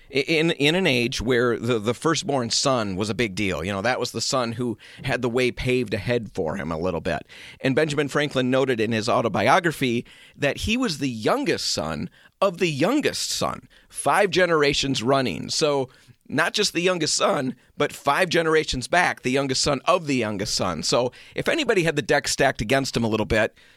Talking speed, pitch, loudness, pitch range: 200 wpm, 130 Hz, -23 LUFS, 120-150 Hz